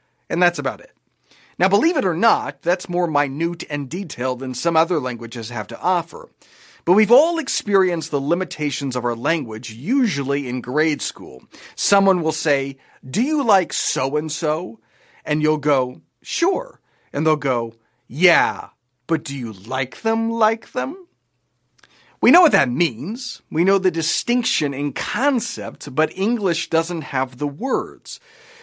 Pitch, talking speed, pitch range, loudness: 160 Hz, 155 wpm, 135-195 Hz, -20 LUFS